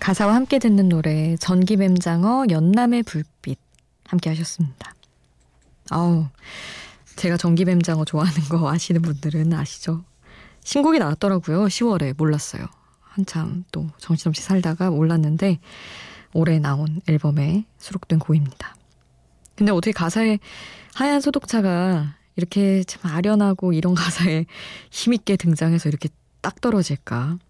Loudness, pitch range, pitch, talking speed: -21 LUFS, 155-195 Hz, 170 Hz, 290 characters per minute